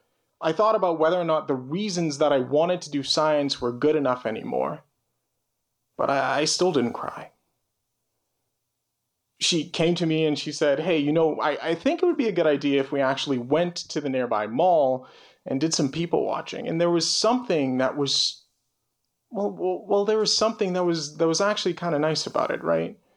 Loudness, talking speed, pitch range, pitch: -24 LUFS, 205 wpm, 135-175 Hz, 155 Hz